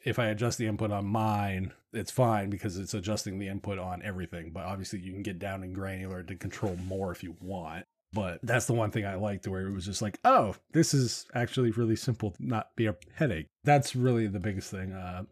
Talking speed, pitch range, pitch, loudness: 230 wpm, 95-115 Hz, 105 Hz, -31 LUFS